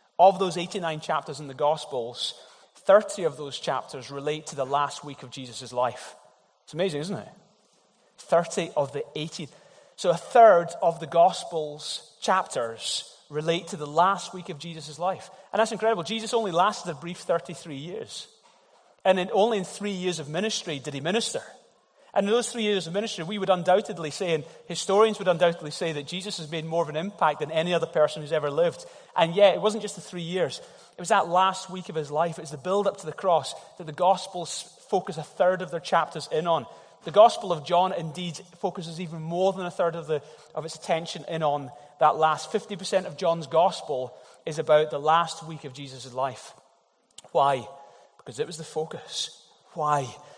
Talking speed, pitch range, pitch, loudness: 200 wpm, 155-190 Hz, 170 Hz, -26 LUFS